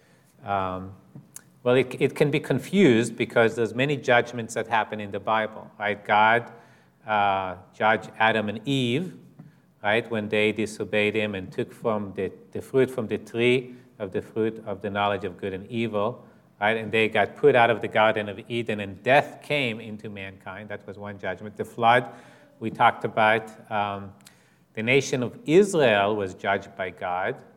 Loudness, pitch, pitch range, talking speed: -24 LUFS, 110 Hz, 100-120 Hz, 175 wpm